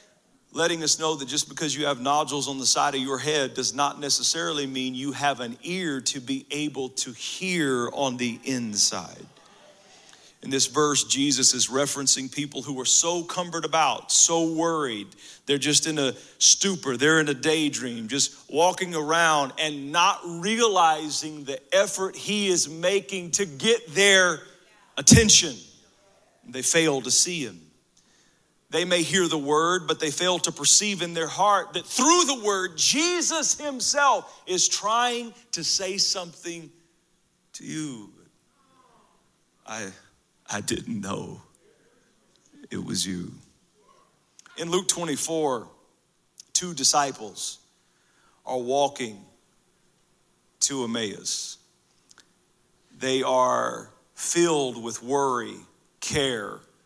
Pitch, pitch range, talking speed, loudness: 155 Hz, 135-180 Hz, 130 wpm, -23 LUFS